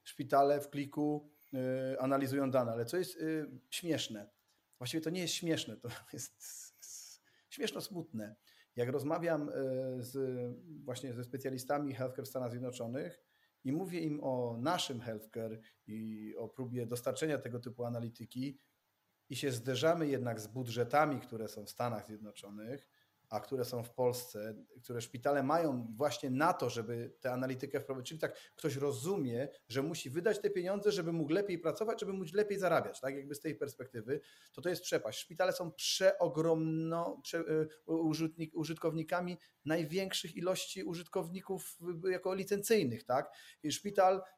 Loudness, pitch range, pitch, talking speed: -37 LUFS, 125-170 Hz, 145 Hz, 150 wpm